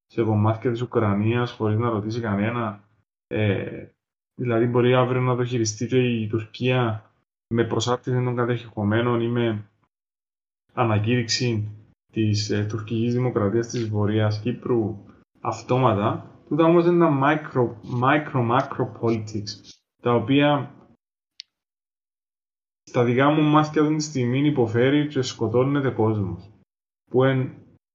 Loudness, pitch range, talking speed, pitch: -23 LUFS, 110-125 Hz, 120 wpm, 120 Hz